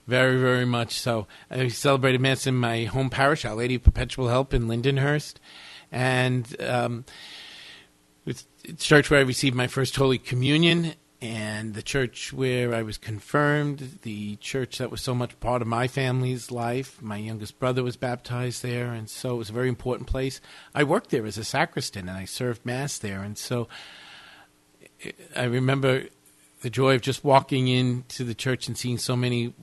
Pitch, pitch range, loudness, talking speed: 125 Hz, 115-135 Hz, -25 LUFS, 180 wpm